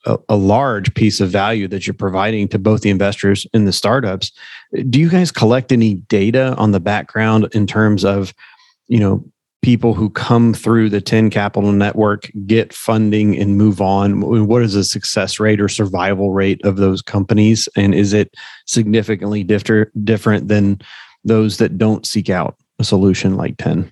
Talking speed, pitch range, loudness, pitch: 175 wpm, 100-110 Hz, -15 LUFS, 105 Hz